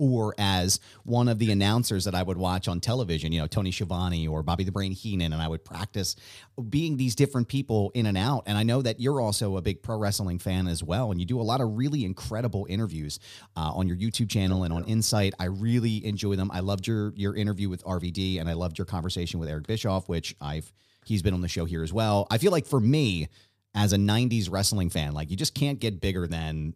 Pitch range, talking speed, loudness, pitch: 90-115 Hz, 240 wpm, -27 LUFS, 100 Hz